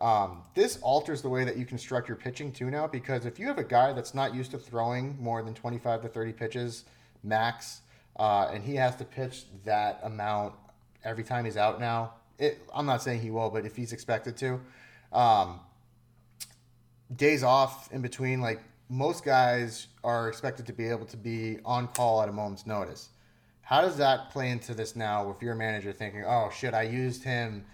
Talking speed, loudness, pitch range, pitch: 195 wpm, -30 LUFS, 110-130 Hz, 120 Hz